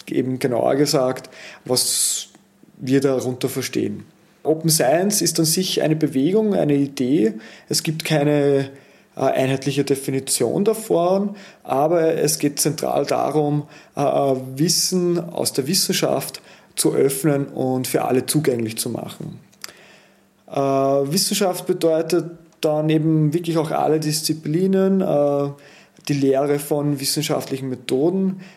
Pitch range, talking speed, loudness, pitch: 135-165 Hz, 120 wpm, -20 LUFS, 150 Hz